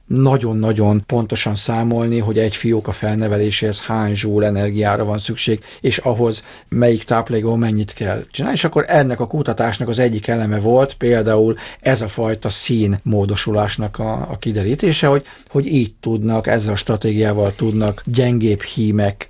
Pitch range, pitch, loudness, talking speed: 105-120 Hz, 110 Hz, -17 LUFS, 150 wpm